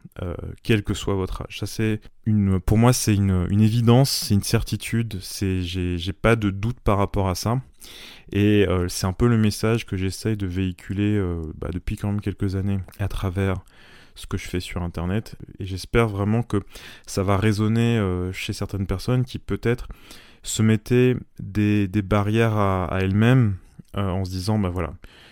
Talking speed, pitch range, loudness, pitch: 195 wpm, 95-110 Hz, -23 LUFS, 100 Hz